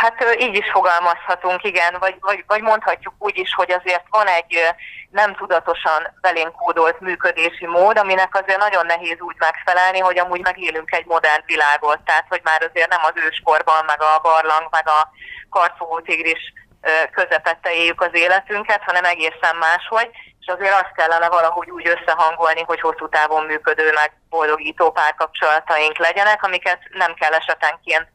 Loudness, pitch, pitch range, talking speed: -17 LUFS, 170 Hz, 160-185 Hz, 155 wpm